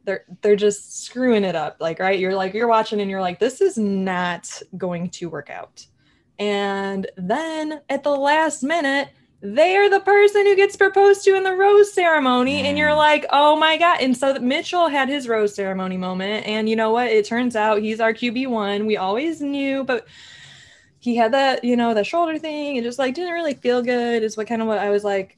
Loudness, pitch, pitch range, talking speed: -19 LUFS, 245 Hz, 205-300 Hz, 215 wpm